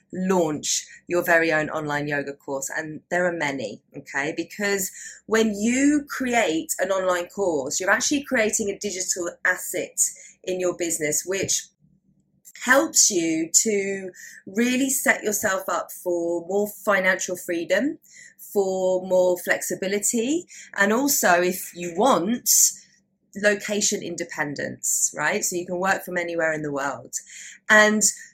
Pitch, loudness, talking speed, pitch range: 190 Hz, -22 LUFS, 130 wpm, 175-215 Hz